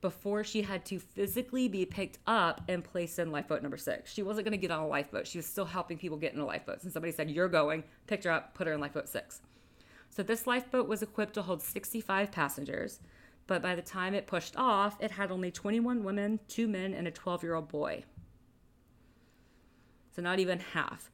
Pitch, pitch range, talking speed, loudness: 185 Hz, 170-210 Hz, 205 wpm, -34 LUFS